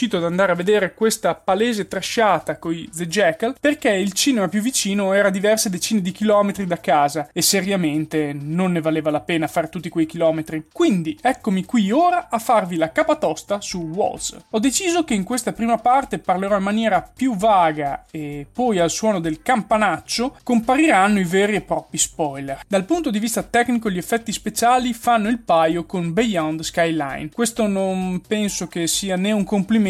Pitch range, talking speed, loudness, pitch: 170-230 Hz, 180 wpm, -20 LUFS, 200 Hz